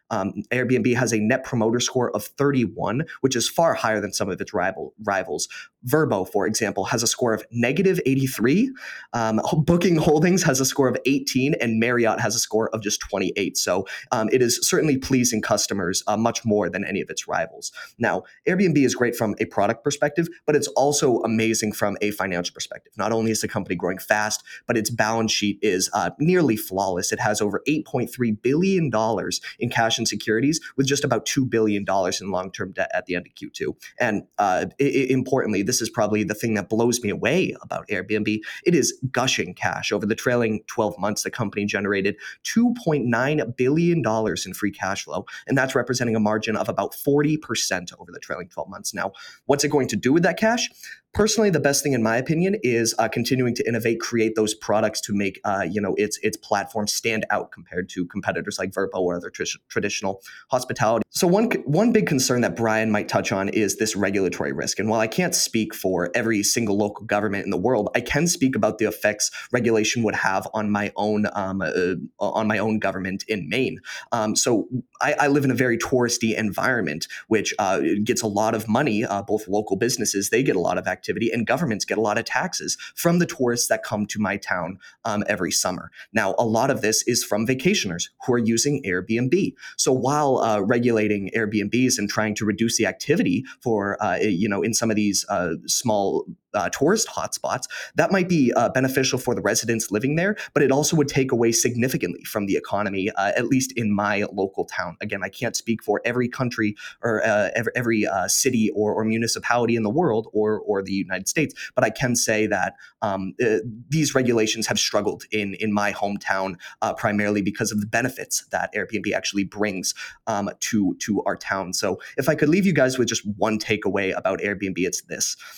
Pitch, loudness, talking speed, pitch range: 115 Hz, -22 LUFS, 205 wpm, 105-130 Hz